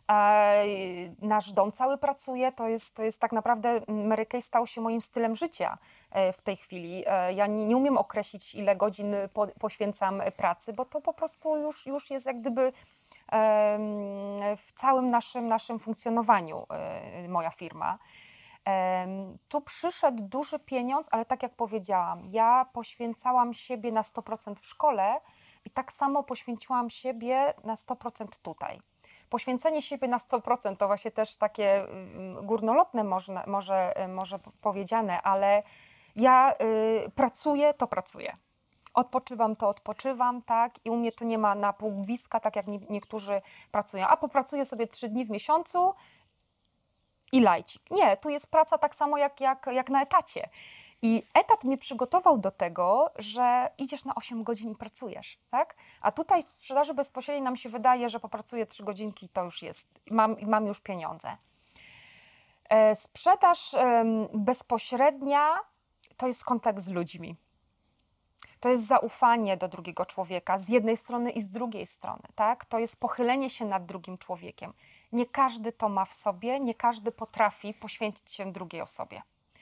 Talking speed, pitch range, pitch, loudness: 150 wpm, 205-255 Hz, 230 Hz, -28 LUFS